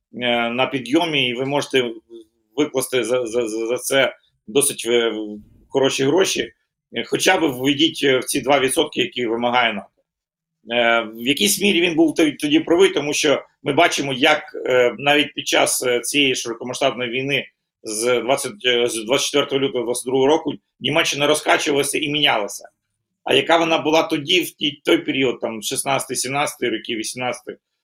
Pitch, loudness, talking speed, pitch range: 135 Hz, -19 LUFS, 135 wpm, 120-150 Hz